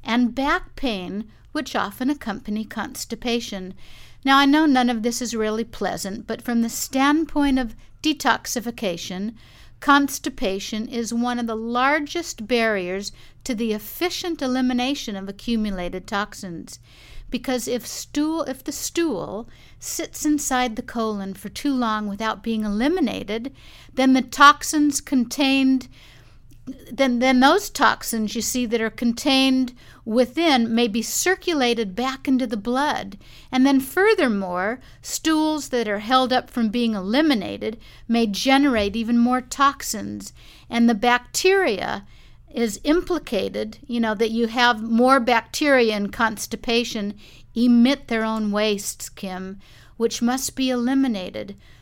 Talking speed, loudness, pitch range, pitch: 130 wpm, -22 LUFS, 215-270 Hz, 240 Hz